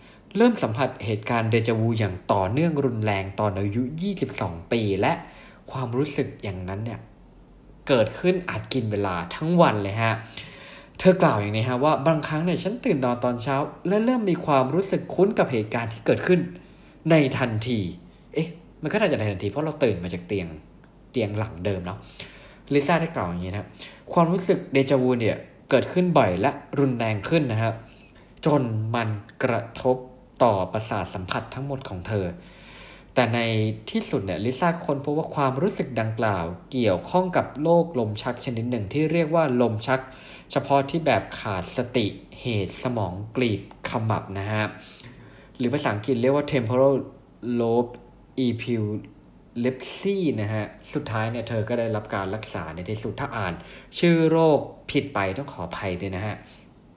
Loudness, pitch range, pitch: -25 LUFS, 105-145 Hz, 125 Hz